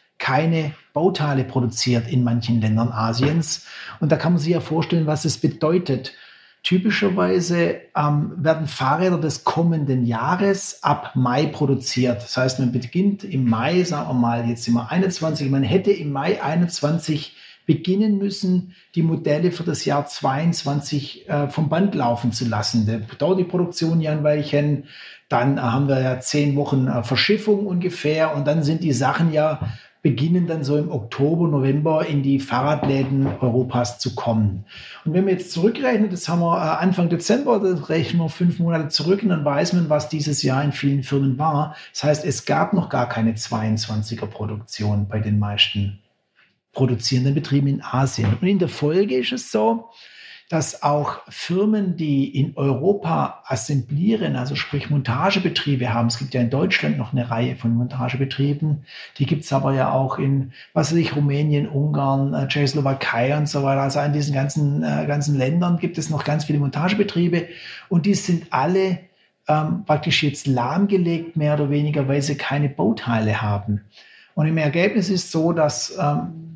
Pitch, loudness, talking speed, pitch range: 145 Hz, -21 LUFS, 170 wpm, 130-170 Hz